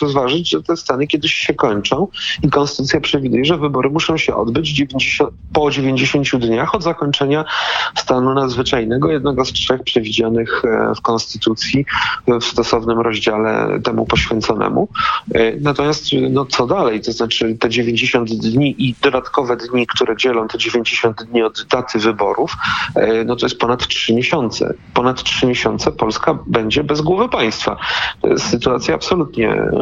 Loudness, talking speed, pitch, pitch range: -16 LUFS, 145 wpm, 130 Hz, 115-145 Hz